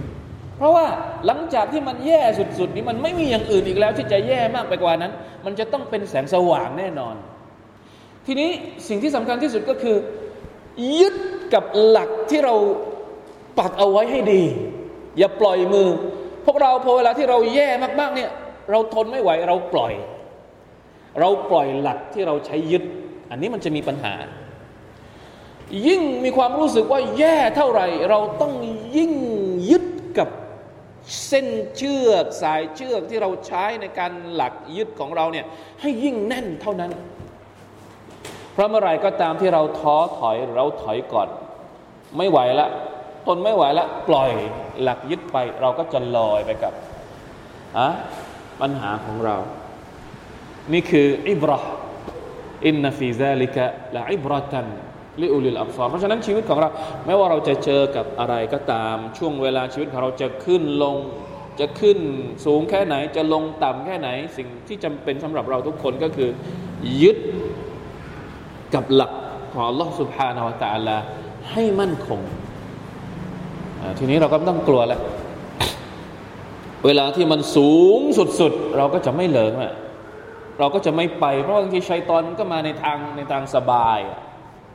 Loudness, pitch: -20 LUFS, 175 Hz